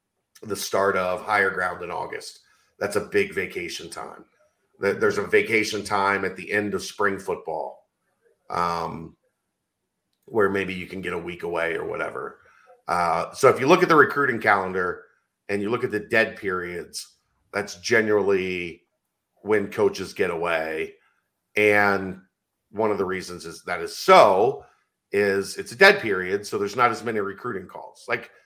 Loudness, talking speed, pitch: -23 LUFS, 160 wpm, 115 Hz